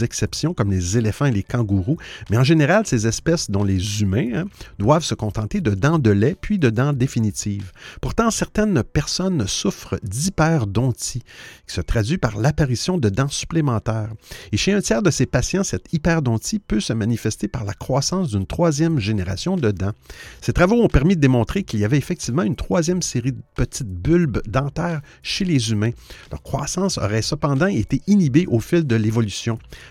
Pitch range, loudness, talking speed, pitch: 110-165 Hz, -20 LUFS, 180 wpm, 125 Hz